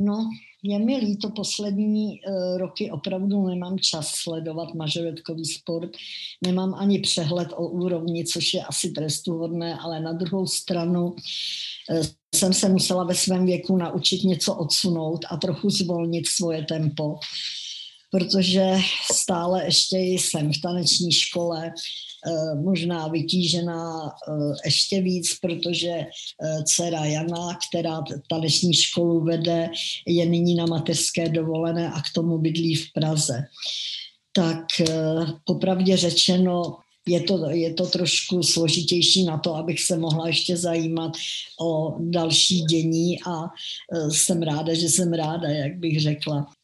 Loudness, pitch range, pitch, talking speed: -23 LUFS, 160-185 Hz, 170 Hz, 125 wpm